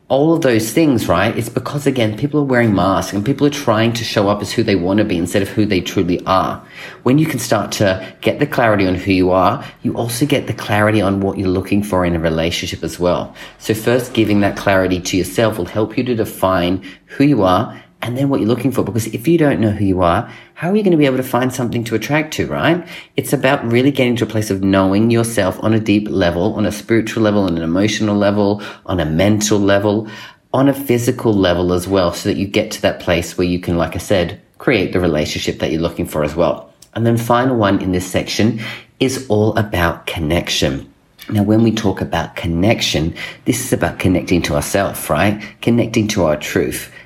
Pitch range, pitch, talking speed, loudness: 95-120 Hz, 105 Hz, 235 wpm, -16 LUFS